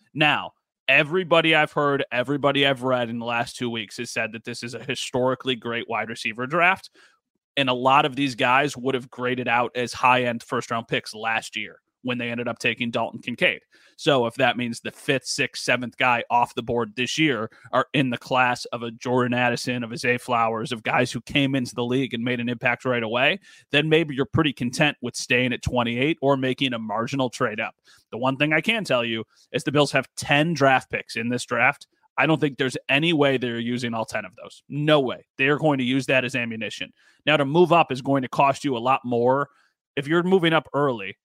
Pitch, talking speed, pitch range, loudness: 125 Hz, 230 wpm, 120-140 Hz, -23 LUFS